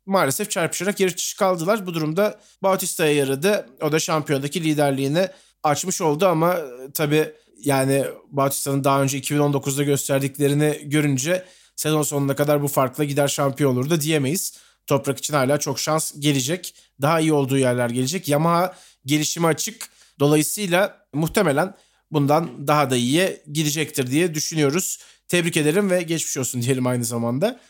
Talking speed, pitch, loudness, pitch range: 140 wpm, 150 Hz, -21 LUFS, 140-175 Hz